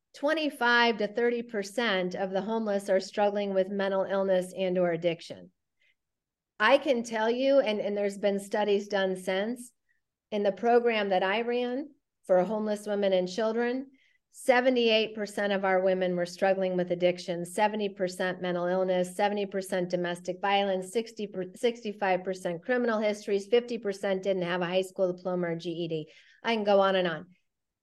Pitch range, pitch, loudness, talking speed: 185-225 Hz, 200 Hz, -28 LUFS, 160 wpm